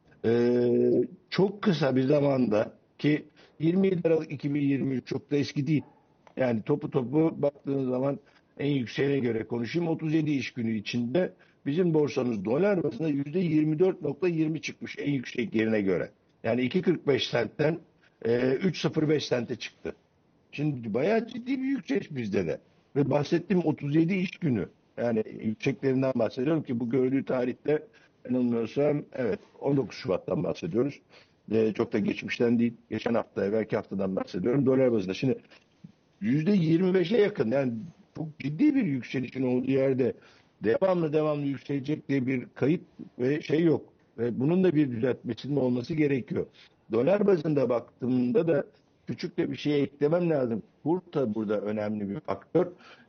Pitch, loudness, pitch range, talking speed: 145 Hz, -28 LUFS, 125-160 Hz, 135 wpm